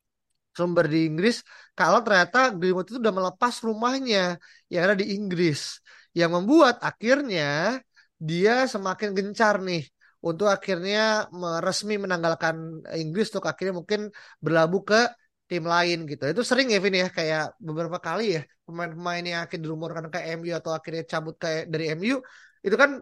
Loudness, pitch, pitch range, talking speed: -25 LUFS, 180 Hz, 165-215 Hz, 150 wpm